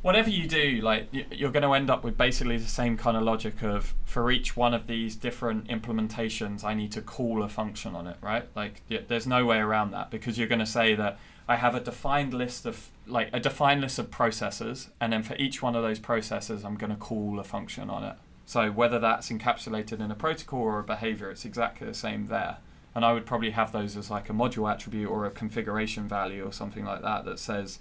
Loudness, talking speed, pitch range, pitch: -29 LUFS, 235 wpm, 105-120 Hz, 115 Hz